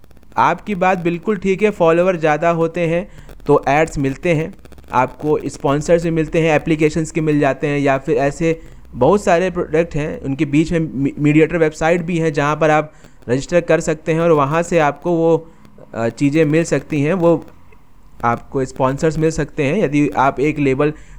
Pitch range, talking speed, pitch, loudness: 145-165 Hz, 175 wpm, 160 Hz, -17 LUFS